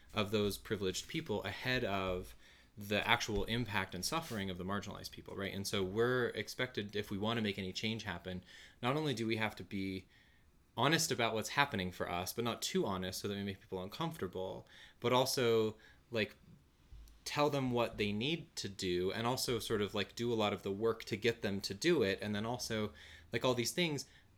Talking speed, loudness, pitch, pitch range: 210 wpm, -37 LUFS, 105 Hz, 95-120 Hz